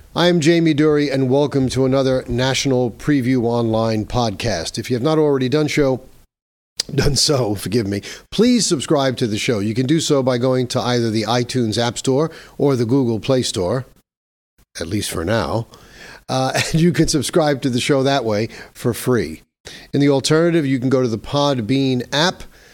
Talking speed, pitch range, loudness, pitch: 185 wpm, 120-145 Hz, -18 LUFS, 130 Hz